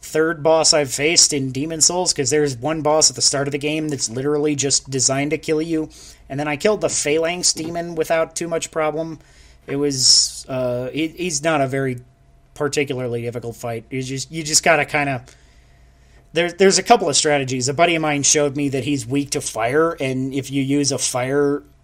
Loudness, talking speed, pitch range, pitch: -18 LUFS, 205 wpm, 135-160 Hz, 145 Hz